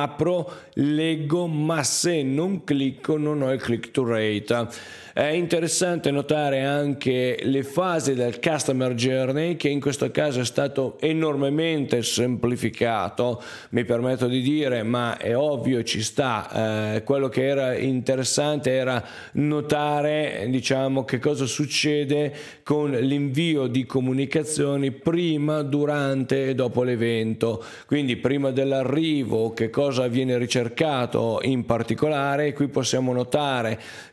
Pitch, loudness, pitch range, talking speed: 135 Hz, -24 LUFS, 125-150 Hz, 125 wpm